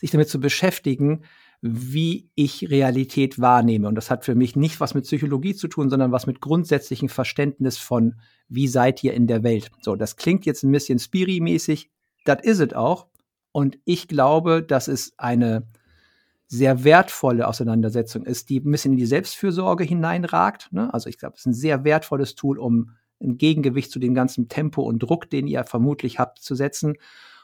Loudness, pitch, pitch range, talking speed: -21 LUFS, 135 Hz, 125-150 Hz, 185 wpm